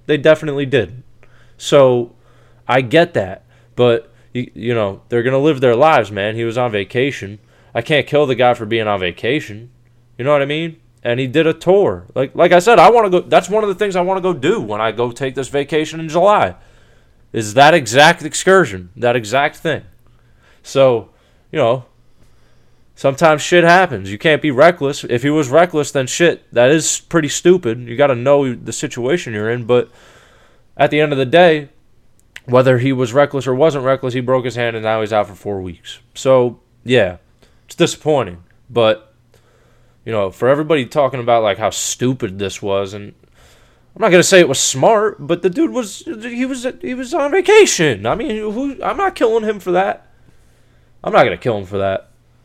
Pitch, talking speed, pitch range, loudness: 130 Hz, 200 wpm, 115-160 Hz, -15 LUFS